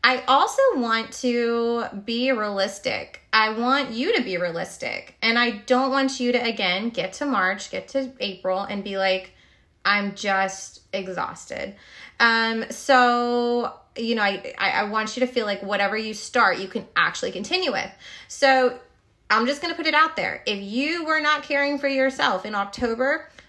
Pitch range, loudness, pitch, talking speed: 205-265 Hz, -23 LUFS, 235 Hz, 175 wpm